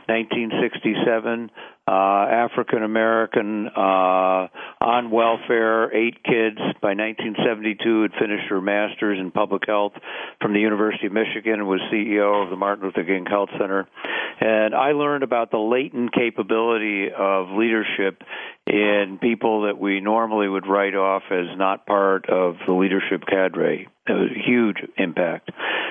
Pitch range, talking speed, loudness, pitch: 95-115 Hz, 145 wpm, -21 LUFS, 105 Hz